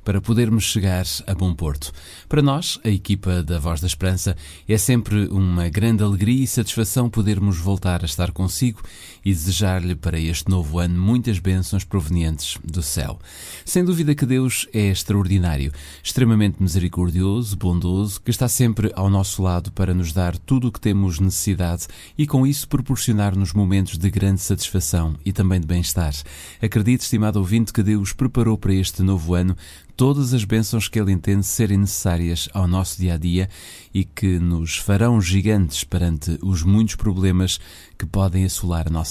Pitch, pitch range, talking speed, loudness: 95 Hz, 90-110 Hz, 165 wpm, -20 LUFS